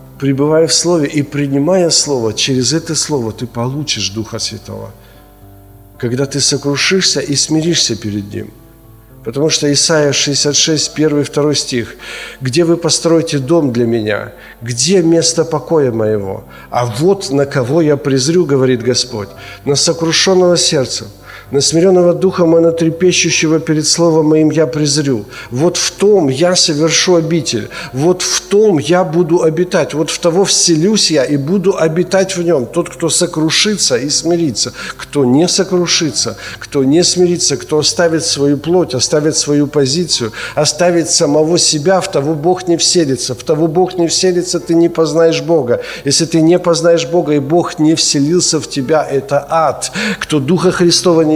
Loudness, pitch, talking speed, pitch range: -12 LUFS, 155 Hz, 150 wpm, 135-170 Hz